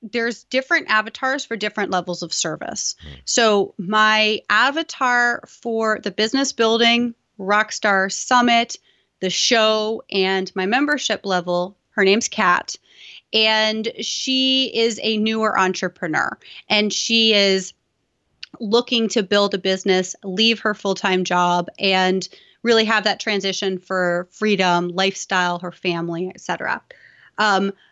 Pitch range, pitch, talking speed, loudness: 190-230 Hz, 210 Hz, 120 wpm, -19 LUFS